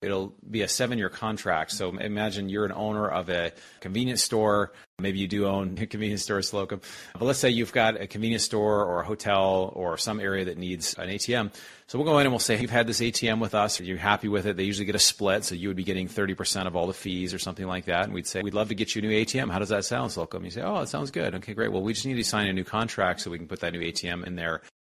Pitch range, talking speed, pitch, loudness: 95-110 Hz, 290 wpm, 105 Hz, -27 LUFS